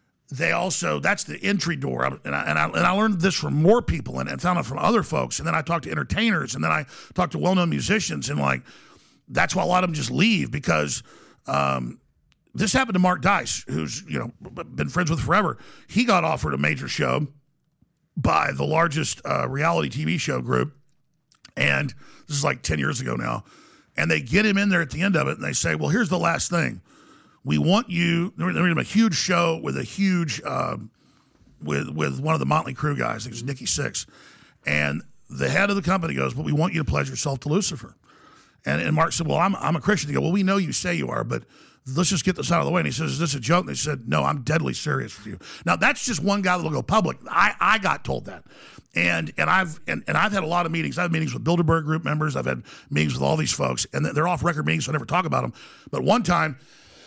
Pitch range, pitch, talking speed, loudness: 135-185 Hz, 165 Hz, 250 wpm, -23 LUFS